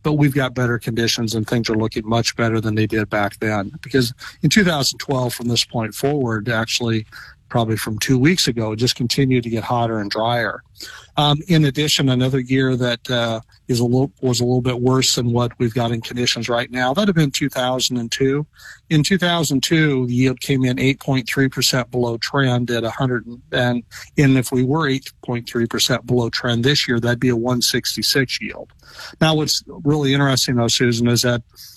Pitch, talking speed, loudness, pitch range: 125 Hz, 185 wpm, -19 LUFS, 115-135 Hz